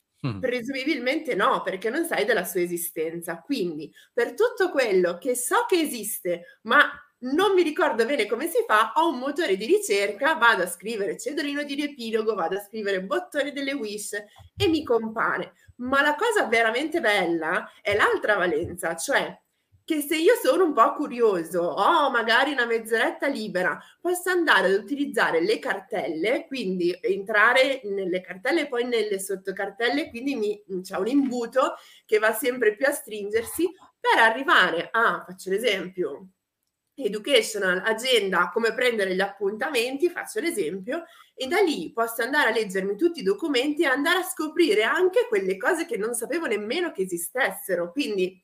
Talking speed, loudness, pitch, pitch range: 160 wpm, -24 LUFS, 255 Hz, 205-330 Hz